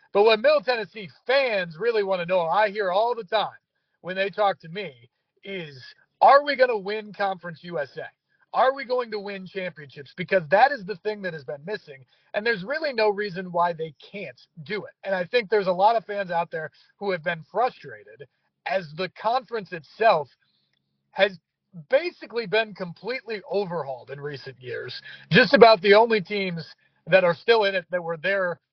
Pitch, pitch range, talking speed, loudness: 195 Hz, 170-215 Hz, 190 wpm, -23 LUFS